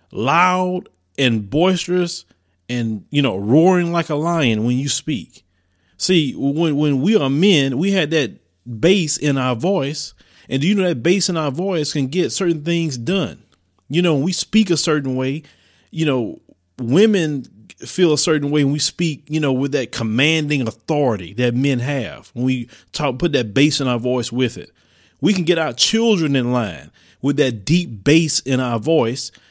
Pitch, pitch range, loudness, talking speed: 145 Hz, 125-170 Hz, -18 LUFS, 185 wpm